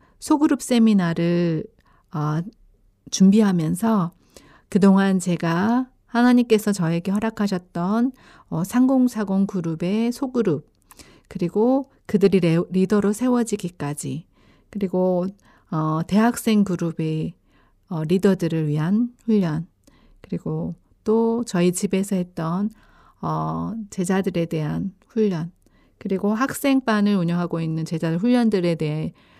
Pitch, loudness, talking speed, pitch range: 190 Hz, -22 LUFS, 245 characters per minute, 165-220 Hz